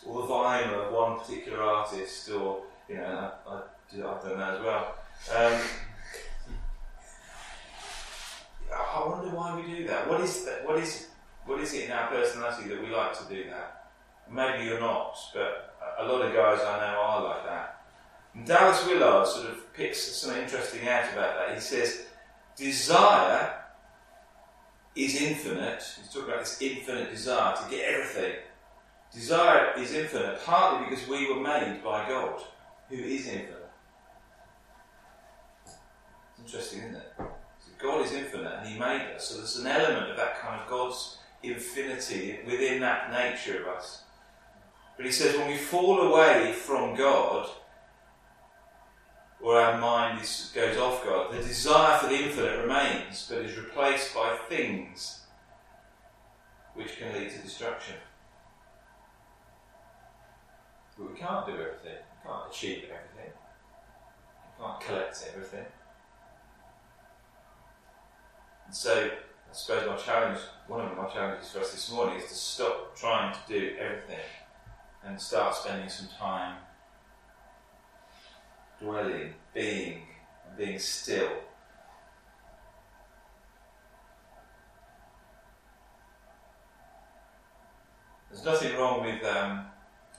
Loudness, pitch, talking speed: -29 LUFS, 135 Hz, 130 wpm